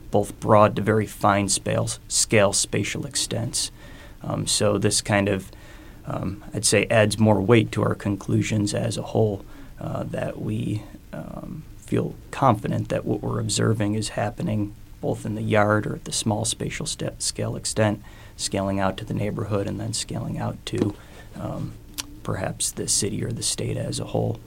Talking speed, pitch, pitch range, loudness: 170 wpm, 105 Hz, 100-110 Hz, -24 LUFS